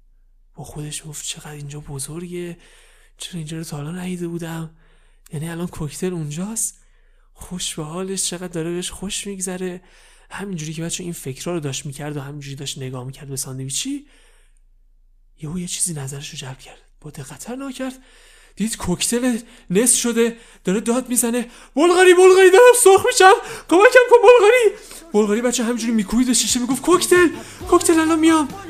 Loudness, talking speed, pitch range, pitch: -17 LUFS, 155 wpm, 155-260 Hz, 185 Hz